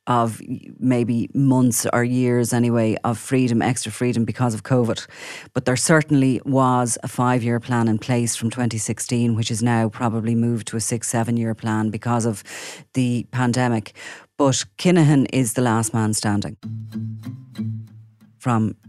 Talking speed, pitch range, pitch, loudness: 155 wpm, 110-125 Hz, 120 Hz, -21 LUFS